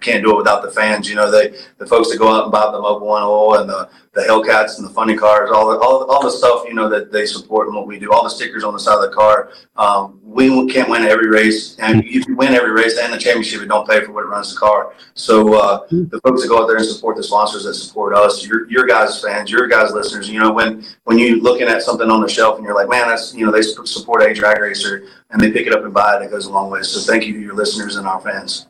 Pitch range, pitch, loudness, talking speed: 105-115 Hz, 110 Hz, -14 LUFS, 300 wpm